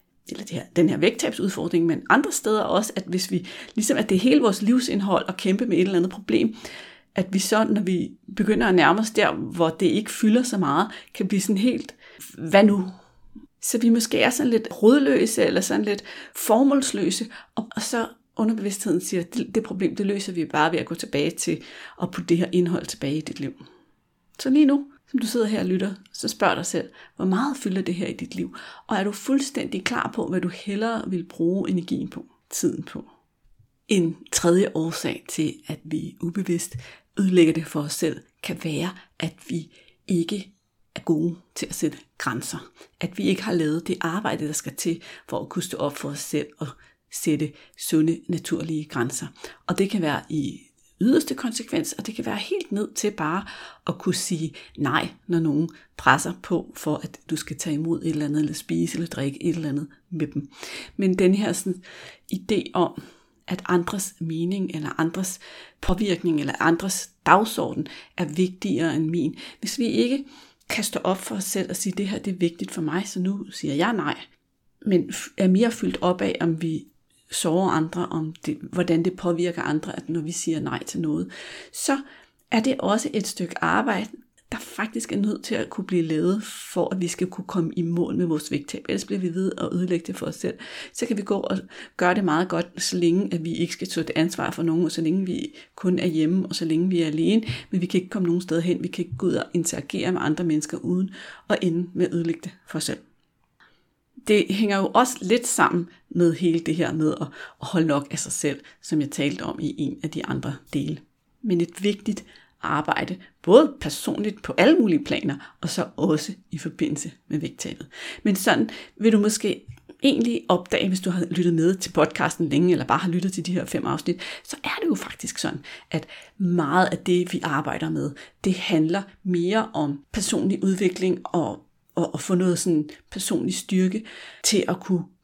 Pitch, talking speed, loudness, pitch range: 180 Hz, 210 wpm, -24 LUFS, 165-205 Hz